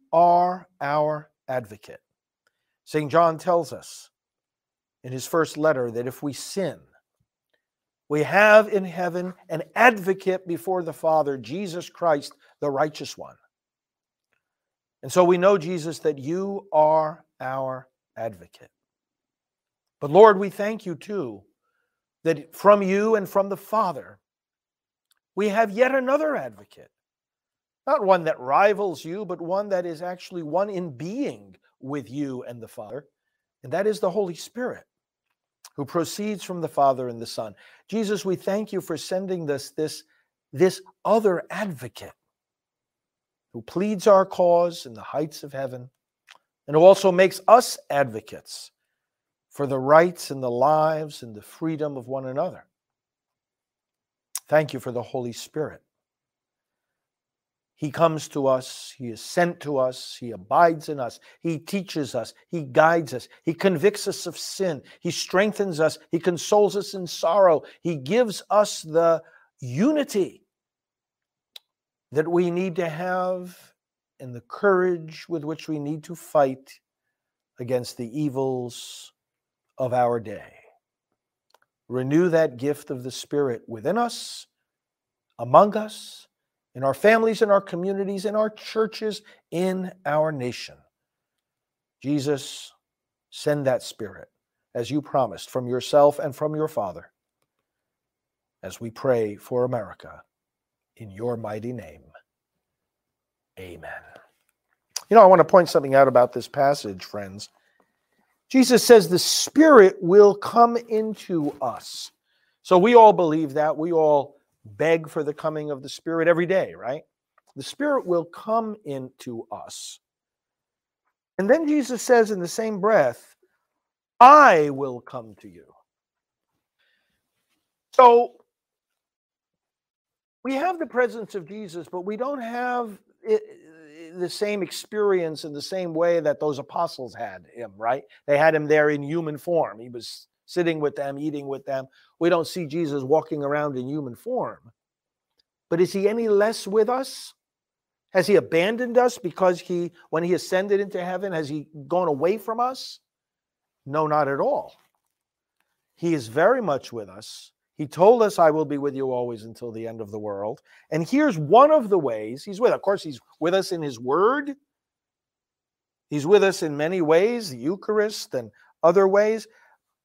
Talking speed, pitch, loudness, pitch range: 145 wpm, 165 Hz, -22 LUFS, 140-200 Hz